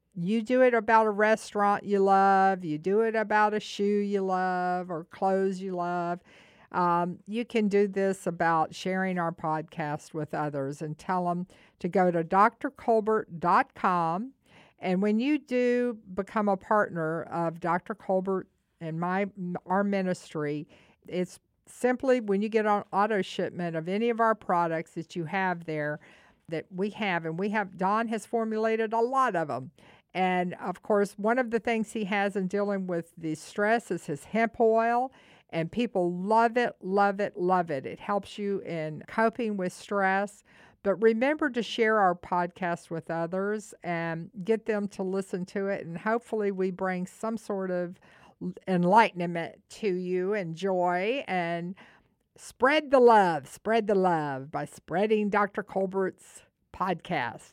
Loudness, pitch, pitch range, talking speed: -28 LUFS, 195 Hz, 175-215 Hz, 160 wpm